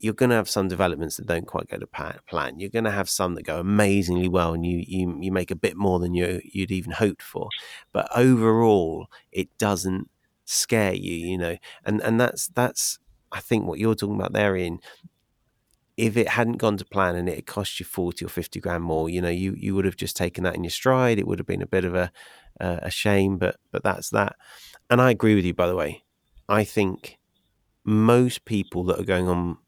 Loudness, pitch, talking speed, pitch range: -24 LUFS, 95 Hz, 225 wpm, 90-105 Hz